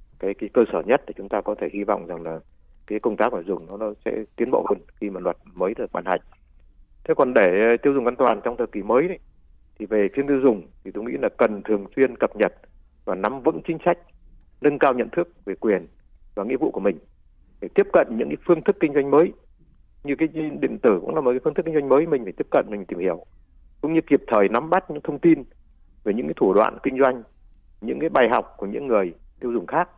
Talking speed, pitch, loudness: 260 wpm, 125 Hz, -22 LUFS